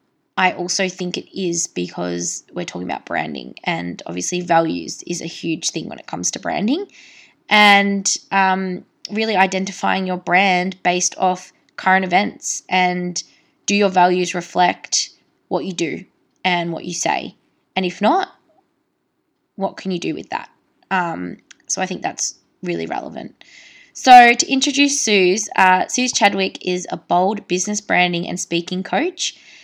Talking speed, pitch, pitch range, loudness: 150 wpm, 185 Hz, 180-210 Hz, -18 LUFS